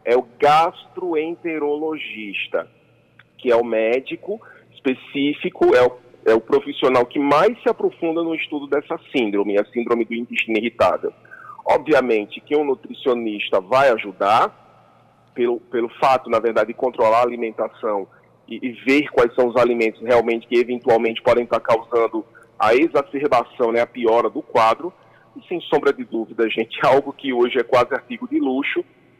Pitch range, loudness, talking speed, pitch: 115-155 Hz, -19 LUFS, 155 wpm, 125 Hz